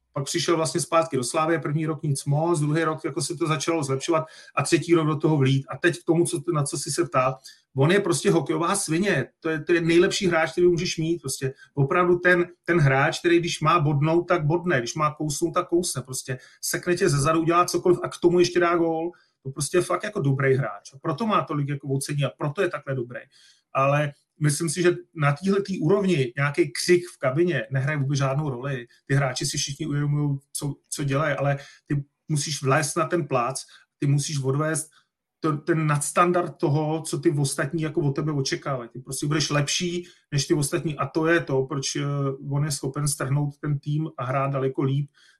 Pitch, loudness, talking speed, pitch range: 155 Hz, -24 LUFS, 210 wpm, 140-170 Hz